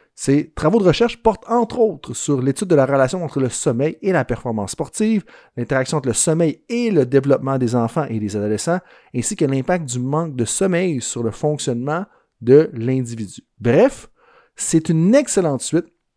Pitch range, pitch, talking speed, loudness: 125-175 Hz, 150 Hz, 180 wpm, -19 LUFS